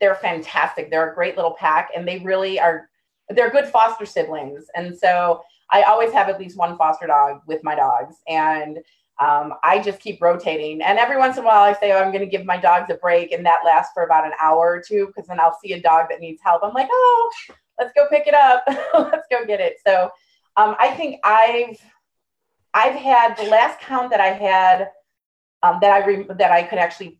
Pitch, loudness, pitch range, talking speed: 190 Hz, -17 LUFS, 170-225 Hz, 225 wpm